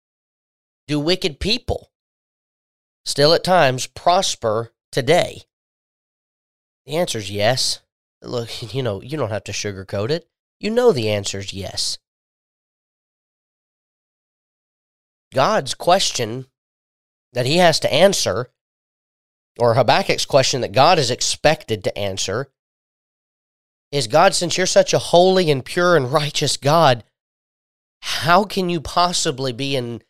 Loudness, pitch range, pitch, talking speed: -18 LUFS, 115-175 Hz, 140 Hz, 120 wpm